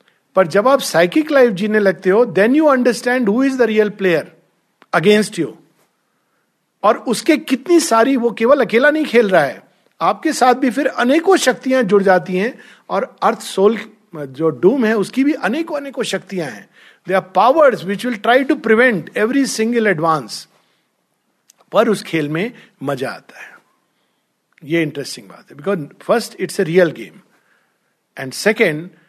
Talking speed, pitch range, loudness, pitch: 165 wpm, 185-255 Hz, -15 LUFS, 215 Hz